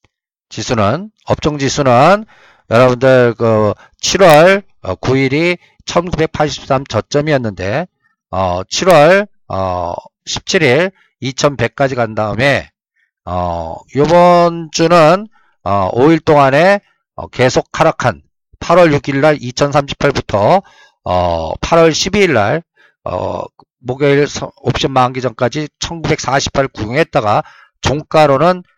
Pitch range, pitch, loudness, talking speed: 120-165 Hz, 140 Hz, -13 LUFS, 160 characters per minute